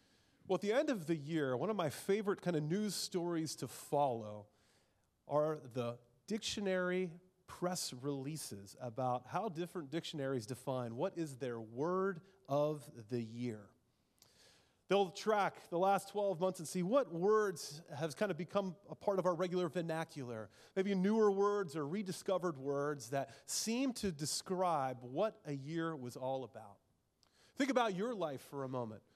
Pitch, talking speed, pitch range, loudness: 165 Hz, 160 wpm, 135-190 Hz, -39 LUFS